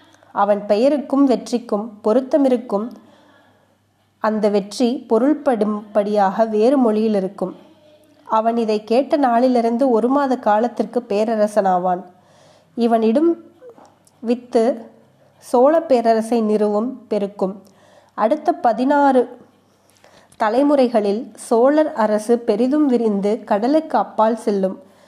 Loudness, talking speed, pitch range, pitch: -18 LUFS, 80 wpm, 210-265 Hz, 230 Hz